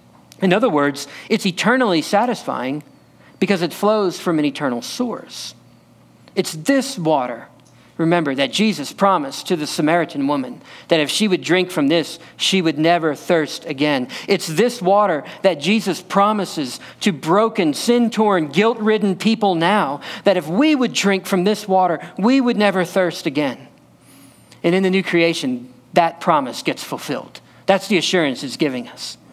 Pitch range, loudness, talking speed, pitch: 160-210 Hz, -18 LUFS, 160 wpm, 185 Hz